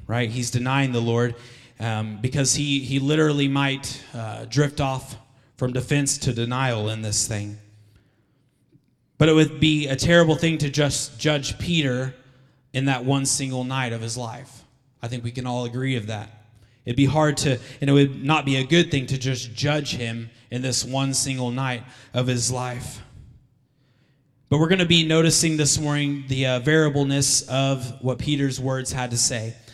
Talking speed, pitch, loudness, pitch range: 180 wpm, 130 Hz, -22 LUFS, 120-140 Hz